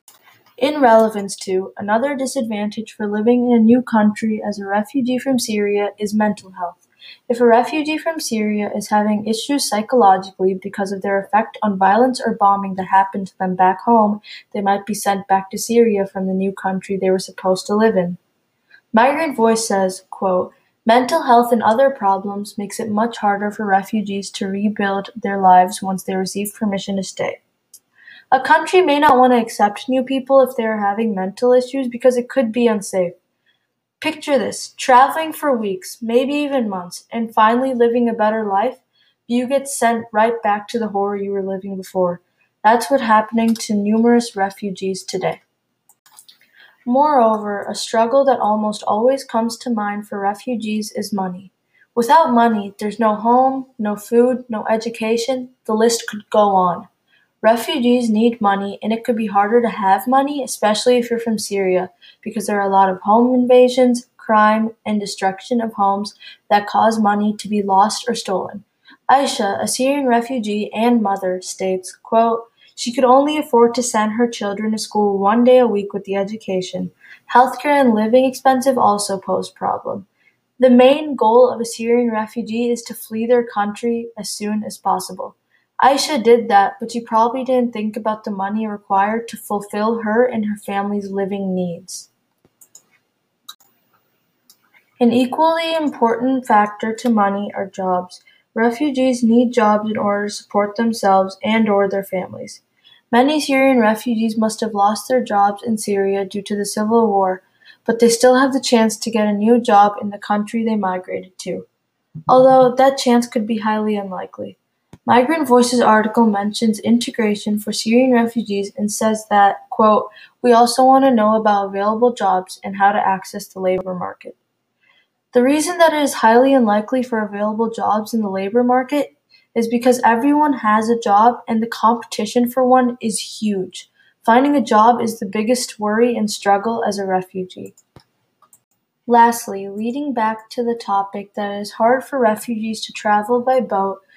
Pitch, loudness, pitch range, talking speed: 220 Hz, -17 LUFS, 200-245 Hz, 170 wpm